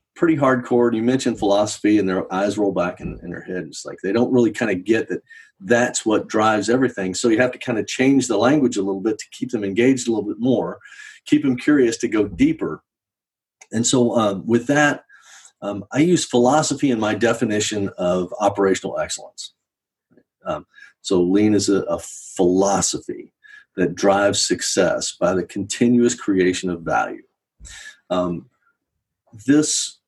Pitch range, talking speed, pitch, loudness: 100-140 Hz, 175 wpm, 120 Hz, -19 LUFS